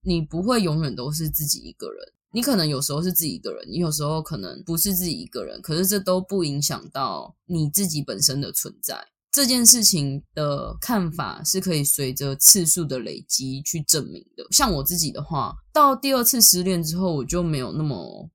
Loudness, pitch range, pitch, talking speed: -20 LUFS, 150-195 Hz, 170 Hz, 305 characters per minute